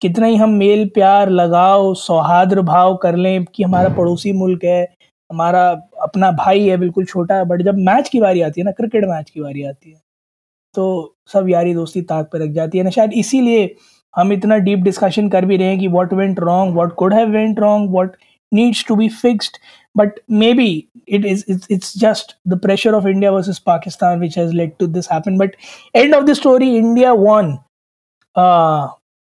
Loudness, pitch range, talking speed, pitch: -14 LUFS, 175-210 Hz, 190 wpm, 190 Hz